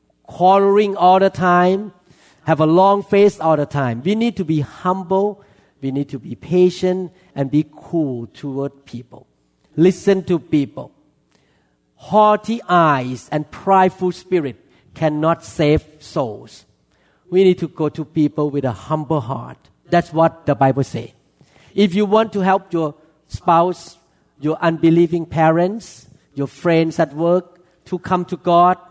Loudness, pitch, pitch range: -17 LUFS, 165 Hz, 145-185 Hz